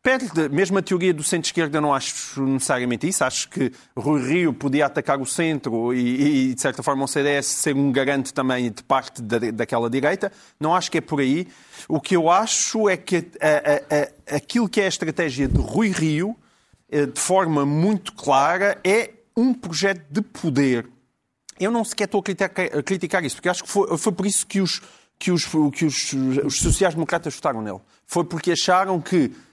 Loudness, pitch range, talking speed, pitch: -21 LUFS, 140-190 Hz, 195 wpm, 160 Hz